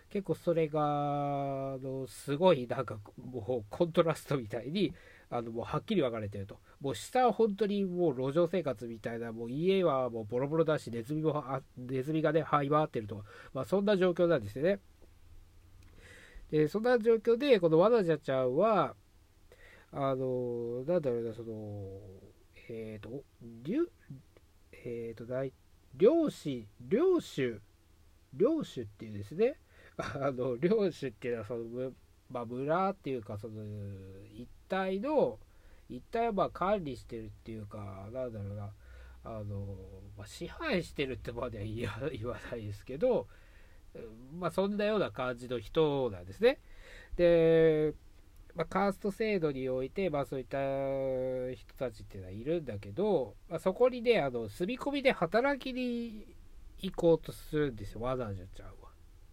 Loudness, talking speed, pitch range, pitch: -33 LUFS, 300 characters per minute, 110-170 Hz, 130 Hz